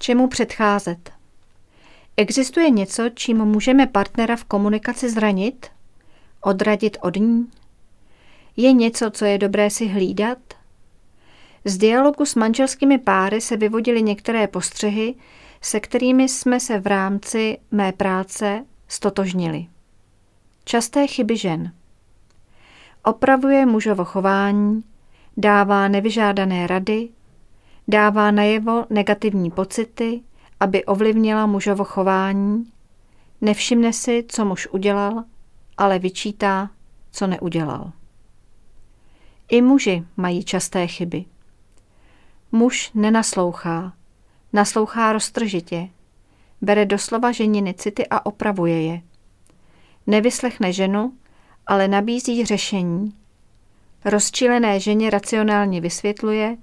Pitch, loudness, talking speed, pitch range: 205 Hz, -19 LUFS, 95 wpm, 185-230 Hz